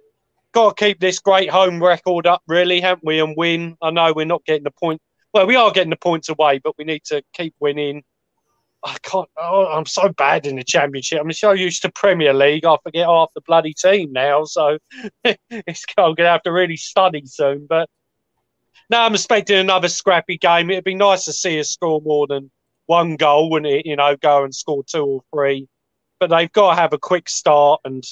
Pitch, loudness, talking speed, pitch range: 170 Hz, -16 LUFS, 215 wpm, 150-190 Hz